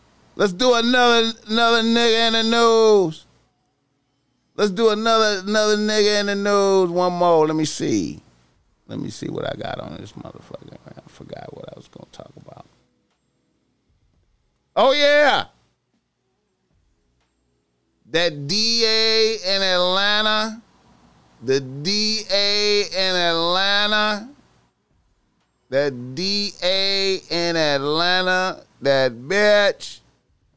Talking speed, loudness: 105 wpm, -18 LUFS